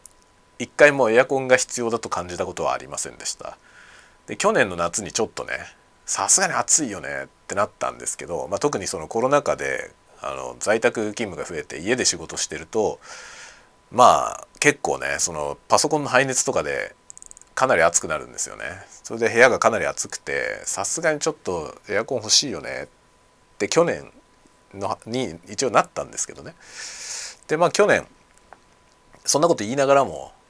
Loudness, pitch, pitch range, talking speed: -22 LUFS, 130 Hz, 115-140 Hz, 345 characters per minute